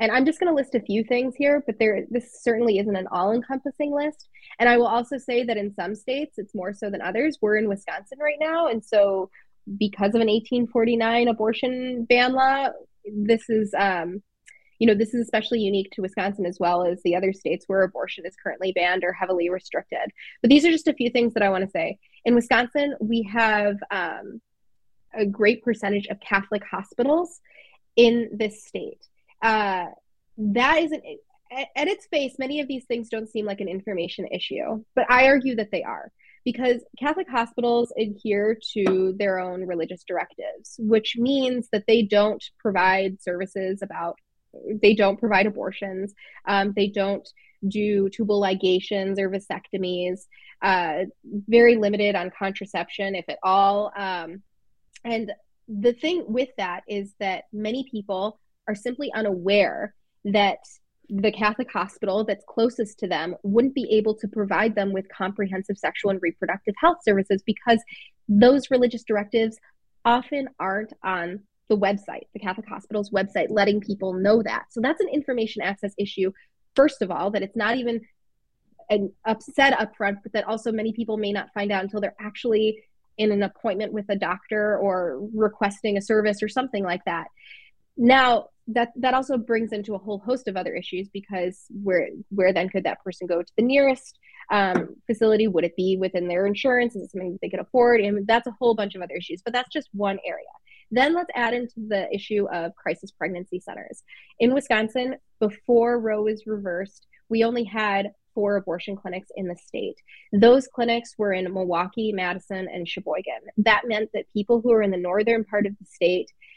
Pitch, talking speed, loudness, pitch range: 215 Hz, 180 wpm, -24 LUFS, 195-240 Hz